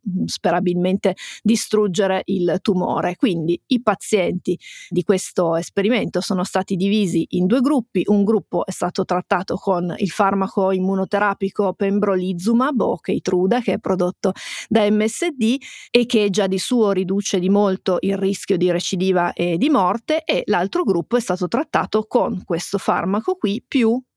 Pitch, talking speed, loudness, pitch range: 195 Hz, 150 wpm, -20 LUFS, 185-215 Hz